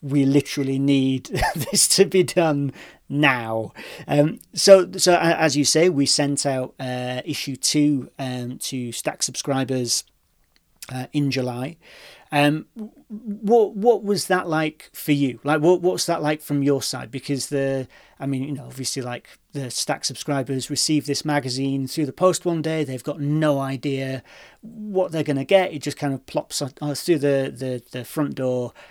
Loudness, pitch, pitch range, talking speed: -21 LUFS, 145 Hz, 130-160 Hz, 170 wpm